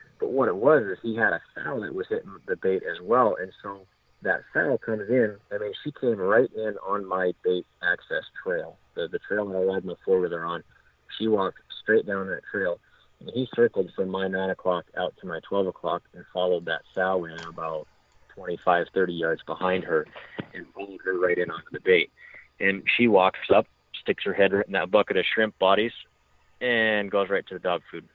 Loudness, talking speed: -26 LUFS, 220 wpm